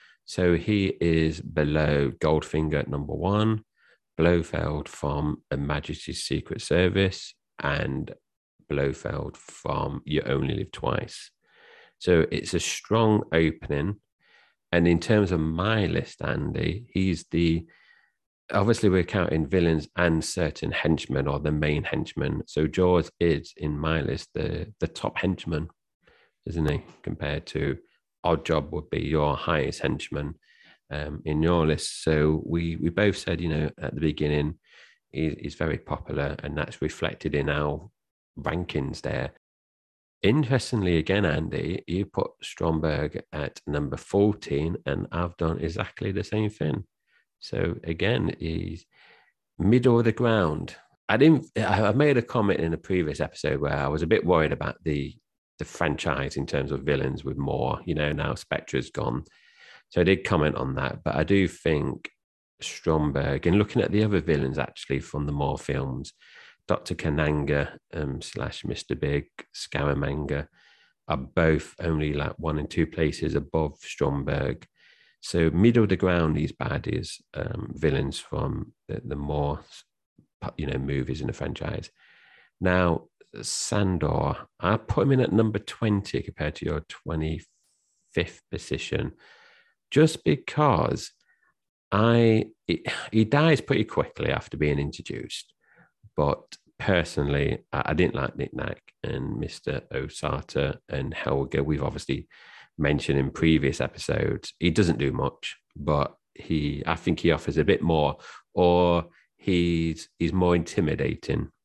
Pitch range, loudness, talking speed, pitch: 75-95 Hz, -26 LUFS, 140 wpm, 80 Hz